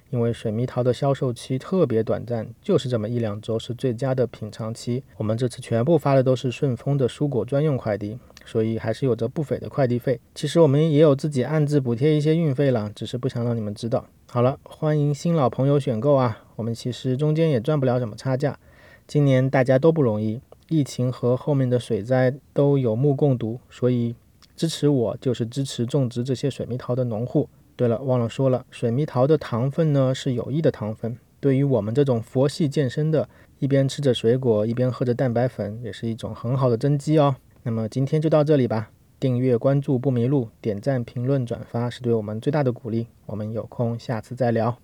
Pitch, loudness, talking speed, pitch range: 125 Hz, -23 LUFS, 325 characters per minute, 115-140 Hz